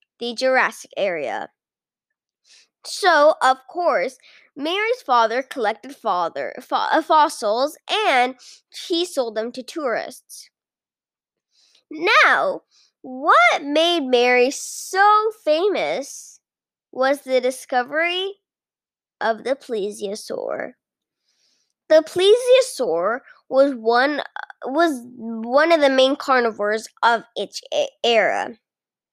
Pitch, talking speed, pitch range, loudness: 280 Hz, 85 wpm, 250-345 Hz, -19 LUFS